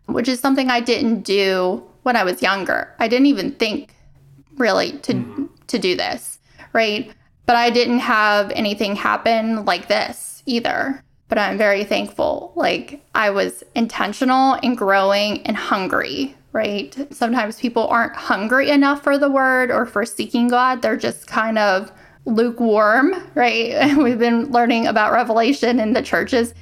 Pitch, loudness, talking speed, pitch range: 235 Hz, -18 LUFS, 155 wpm, 215-260 Hz